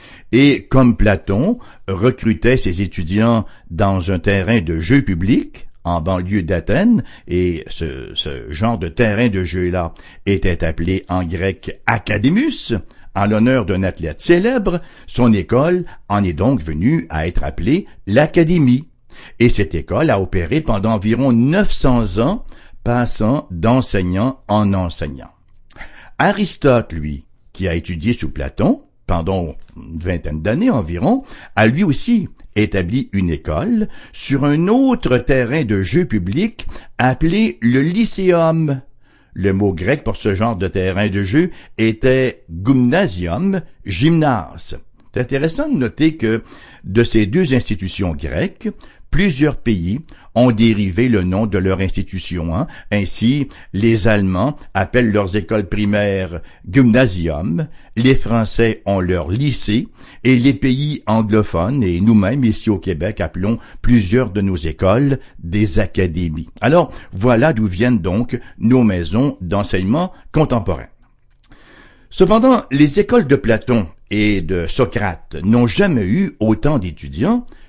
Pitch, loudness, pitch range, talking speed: 110 Hz, -17 LUFS, 95-130 Hz, 130 wpm